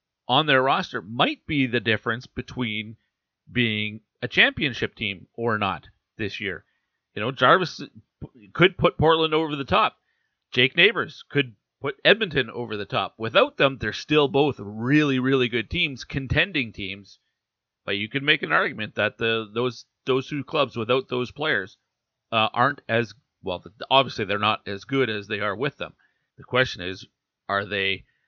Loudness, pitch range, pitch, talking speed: -23 LUFS, 105-135 Hz, 120 Hz, 165 wpm